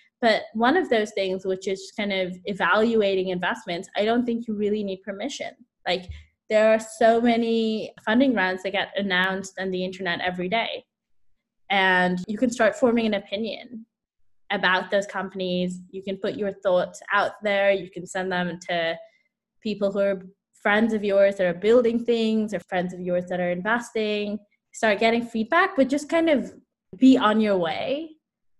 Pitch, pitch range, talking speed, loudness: 205 Hz, 185-230 Hz, 175 wpm, -23 LUFS